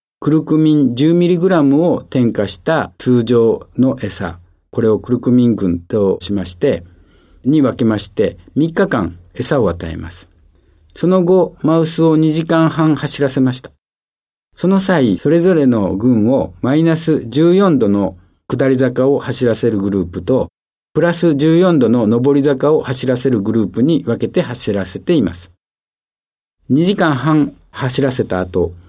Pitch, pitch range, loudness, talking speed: 125 Hz, 95-155 Hz, -14 LUFS, 260 characters per minute